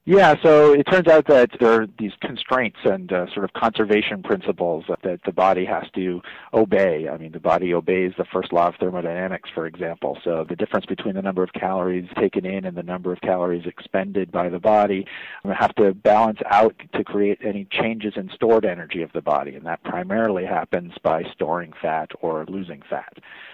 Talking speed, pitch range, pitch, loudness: 200 wpm, 90-110 Hz, 95 Hz, -21 LUFS